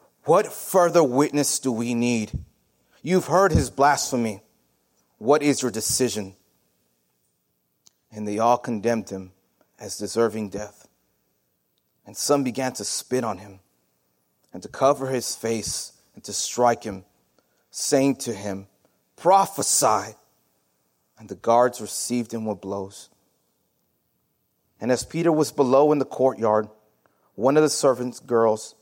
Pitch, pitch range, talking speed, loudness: 115 Hz, 95-130 Hz, 130 wpm, -22 LUFS